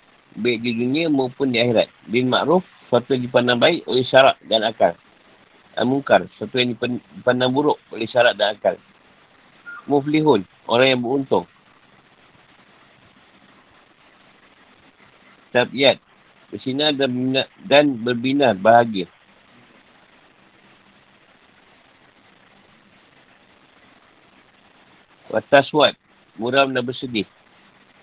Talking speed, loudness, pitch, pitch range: 85 wpm, -19 LUFS, 125 Hz, 105-135 Hz